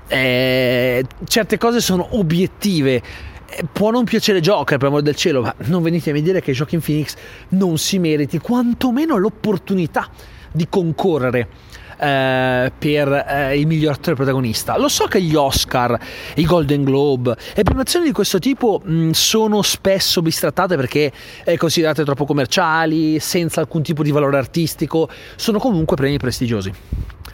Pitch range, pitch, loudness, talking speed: 135-185 Hz, 160 Hz, -17 LUFS, 150 wpm